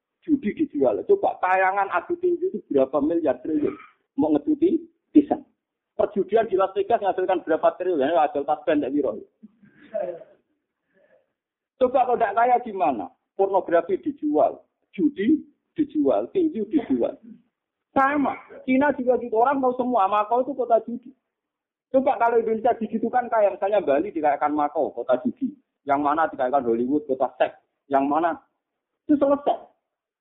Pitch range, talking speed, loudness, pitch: 190-300 Hz, 135 wpm, -23 LUFS, 240 Hz